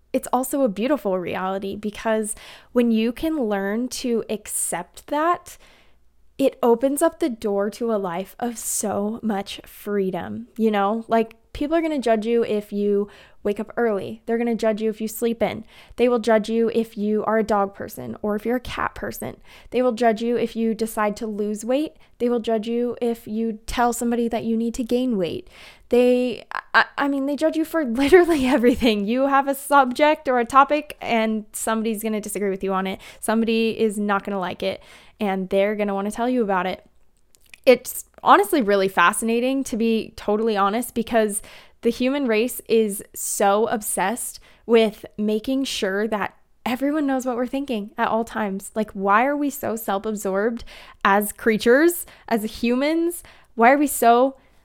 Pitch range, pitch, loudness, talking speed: 210-250 Hz, 225 Hz, -22 LUFS, 185 wpm